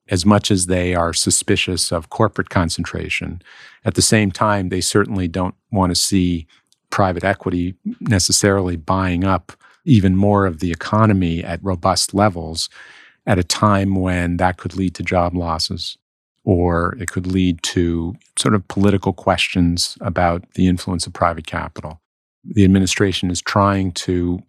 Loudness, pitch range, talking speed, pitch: -18 LUFS, 90-100 Hz, 150 wpm, 95 Hz